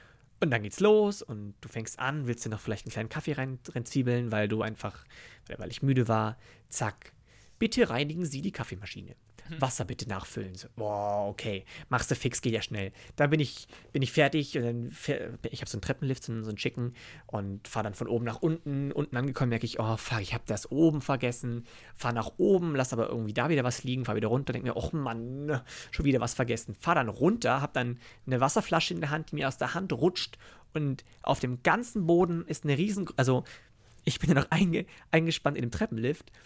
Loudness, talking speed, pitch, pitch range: -30 LUFS, 215 wpm, 125 Hz, 115-150 Hz